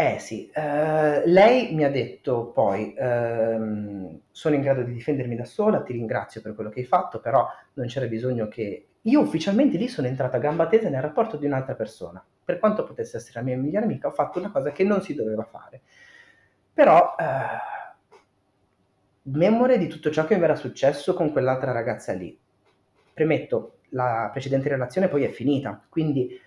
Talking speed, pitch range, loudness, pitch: 180 wpm, 125-170 Hz, -24 LUFS, 140 Hz